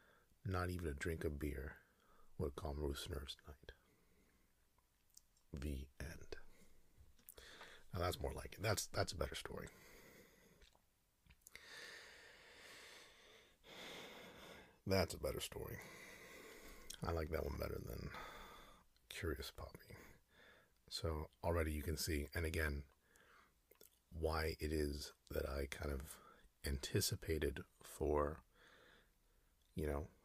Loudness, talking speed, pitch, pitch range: -45 LUFS, 105 wpm, 80 Hz, 70-90 Hz